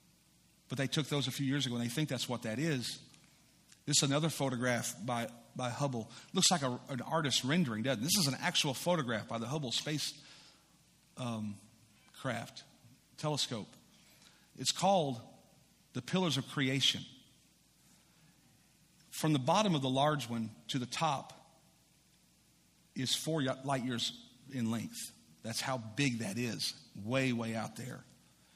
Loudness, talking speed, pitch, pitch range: -34 LUFS, 155 wpm, 135 Hz, 120-155 Hz